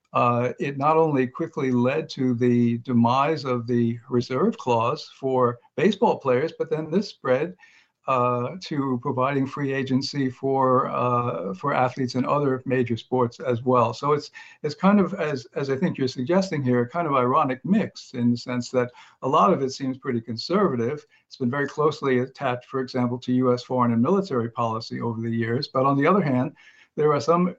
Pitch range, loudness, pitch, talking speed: 125-150 Hz, -24 LUFS, 130 Hz, 190 wpm